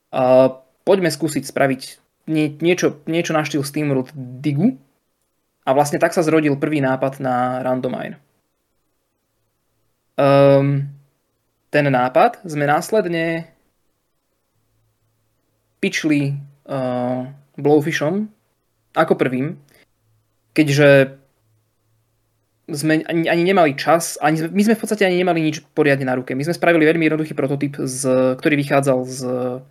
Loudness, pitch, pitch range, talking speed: -18 LUFS, 140 Hz, 130-160 Hz, 115 wpm